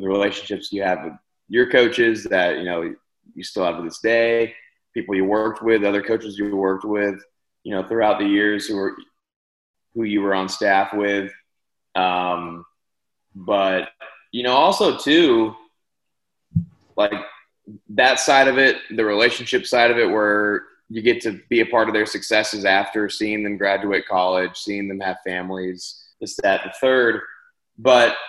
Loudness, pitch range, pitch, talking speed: -20 LUFS, 95-115 Hz, 105 Hz, 165 wpm